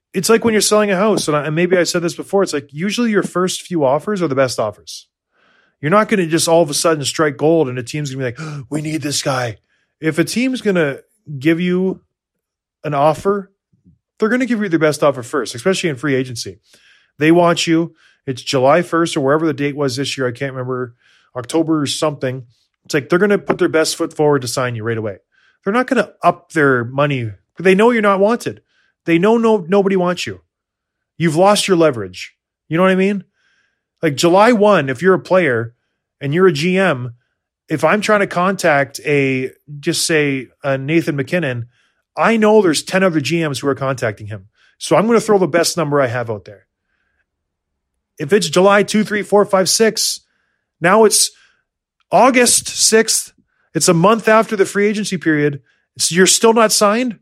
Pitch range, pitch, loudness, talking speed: 135-195 Hz, 165 Hz, -15 LUFS, 210 wpm